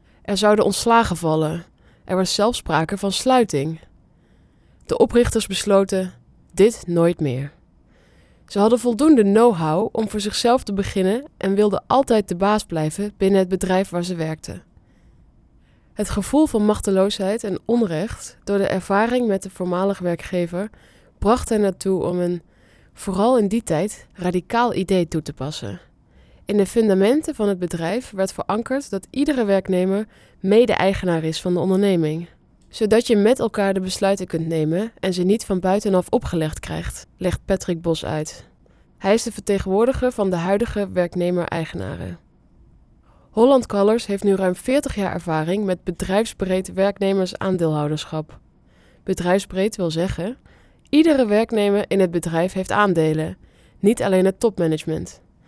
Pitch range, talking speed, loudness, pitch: 175-210 Hz, 145 wpm, -20 LUFS, 195 Hz